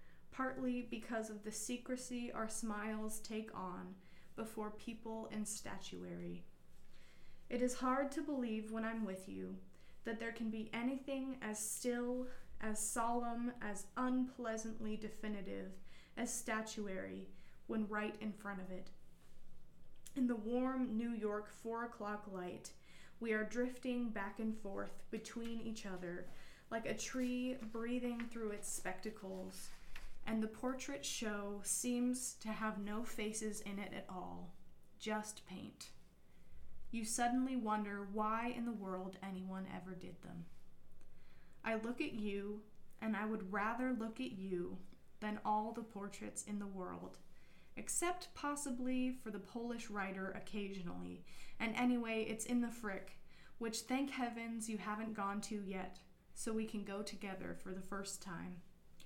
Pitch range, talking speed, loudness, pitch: 195-235 Hz, 140 wpm, -43 LUFS, 215 Hz